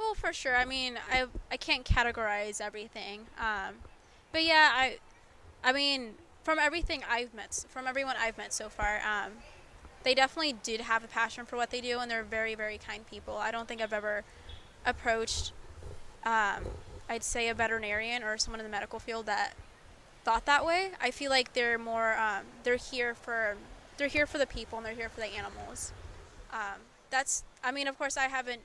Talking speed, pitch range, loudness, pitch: 195 wpm, 220-260 Hz, -32 LUFS, 235 Hz